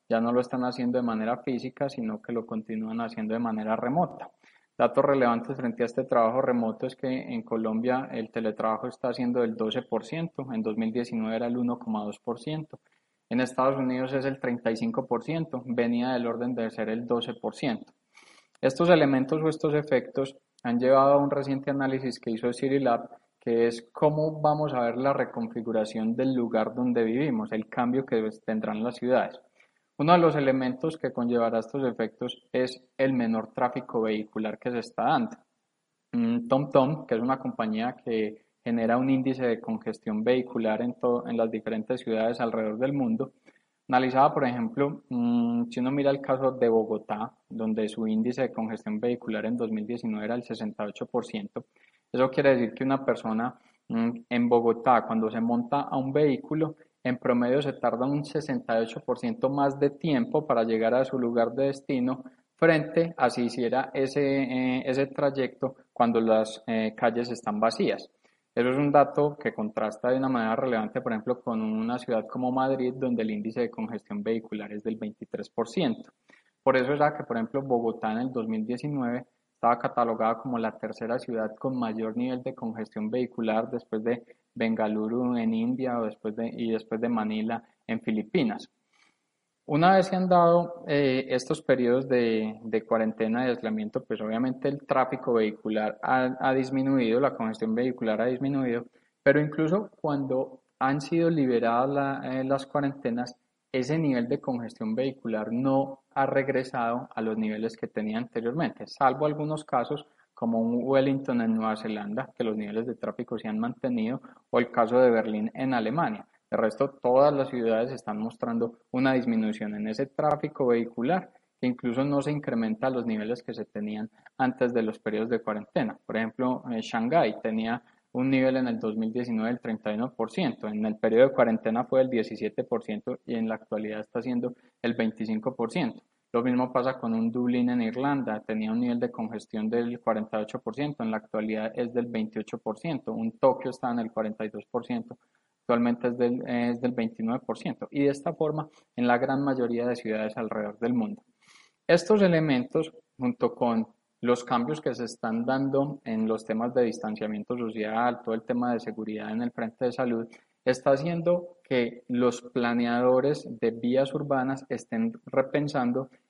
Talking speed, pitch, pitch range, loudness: 165 wpm, 125 Hz, 115-135 Hz, -28 LUFS